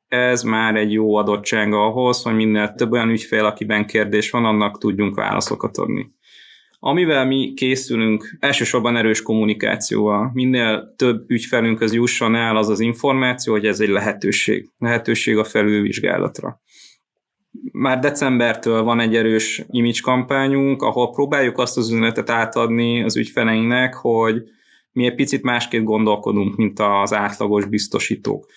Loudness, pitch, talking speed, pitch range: -18 LUFS, 115 Hz, 135 wpm, 105-125 Hz